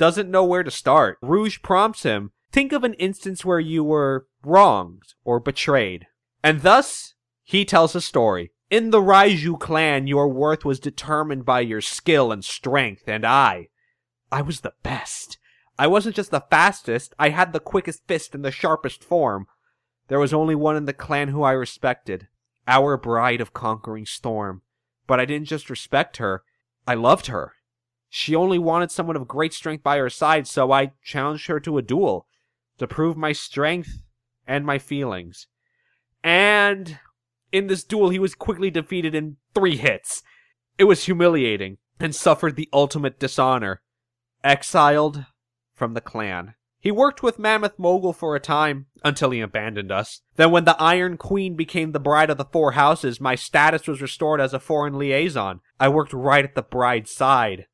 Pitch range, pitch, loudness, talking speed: 125-165 Hz, 145 Hz, -20 LUFS, 175 wpm